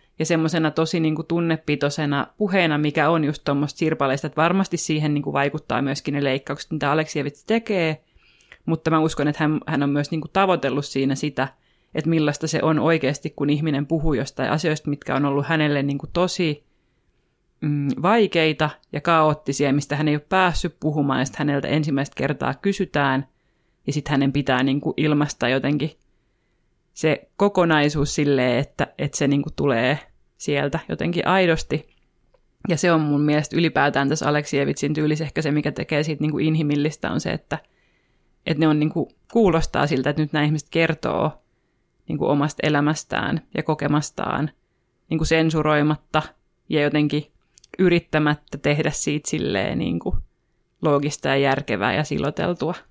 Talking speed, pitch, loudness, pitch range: 160 wpm, 150 Hz, -22 LUFS, 145-160 Hz